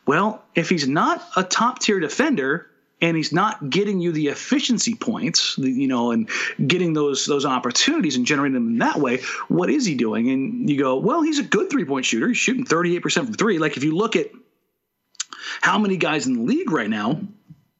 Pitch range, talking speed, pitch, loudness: 155-250 Hz, 210 wpm, 200 Hz, -21 LUFS